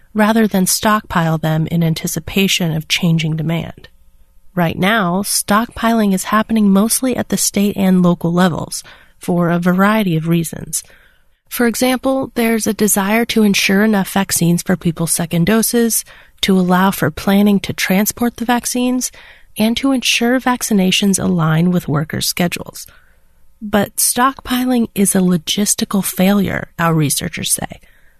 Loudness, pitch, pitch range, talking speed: -15 LUFS, 195 Hz, 170-225 Hz, 135 wpm